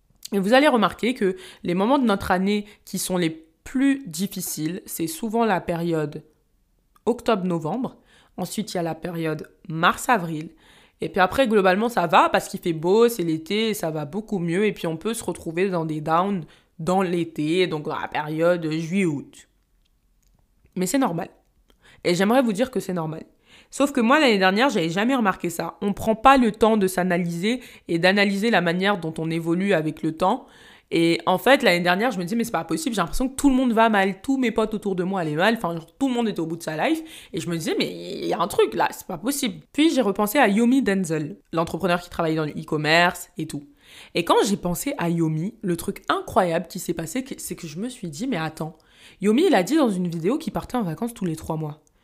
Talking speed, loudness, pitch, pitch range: 230 wpm, -23 LUFS, 185 Hz, 165-225 Hz